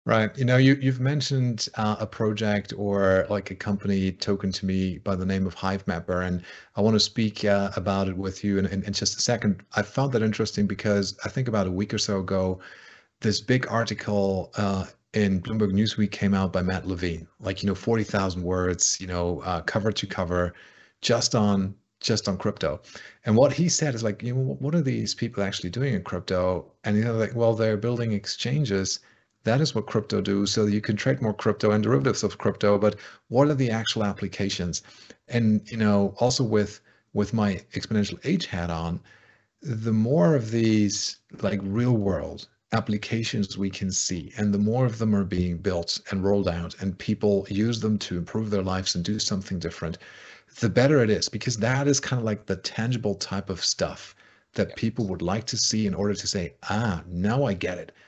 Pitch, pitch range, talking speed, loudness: 105 Hz, 95-115 Hz, 205 wpm, -25 LUFS